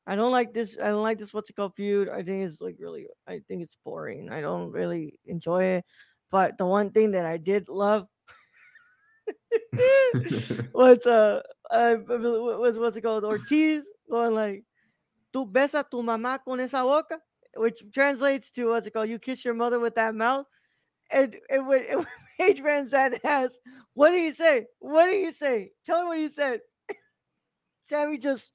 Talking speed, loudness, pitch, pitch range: 180 wpm, -25 LUFS, 245 Hz, 215-295 Hz